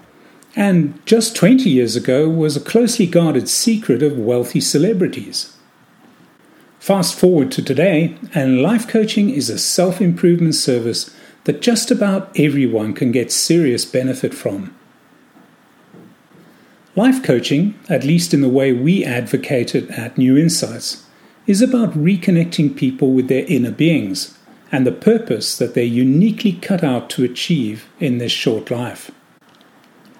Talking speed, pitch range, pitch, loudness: 135 wpm, 130-200 Hz, 155 Hz, -16 LUFS